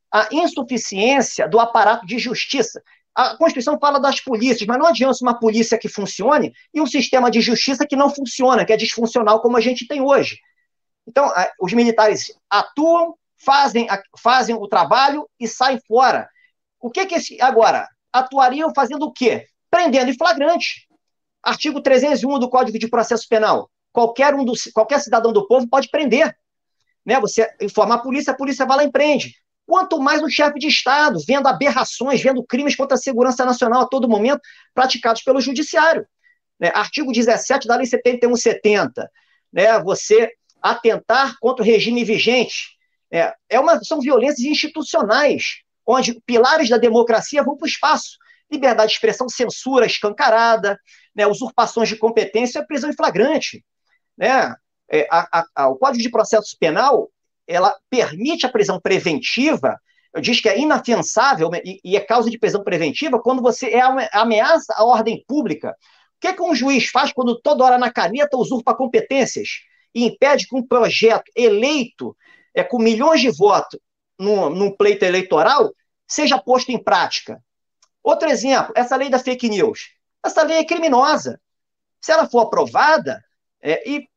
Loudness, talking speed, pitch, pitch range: -17 LUFS, 160 wpm, 255 Hz, 230-295 Hz